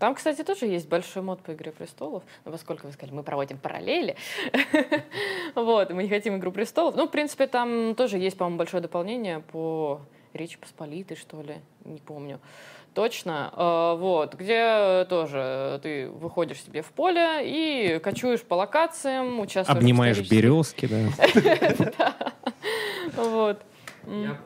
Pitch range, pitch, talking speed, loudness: 155-245 Hz, 185 Hz, 140 wpm, -25 LUFS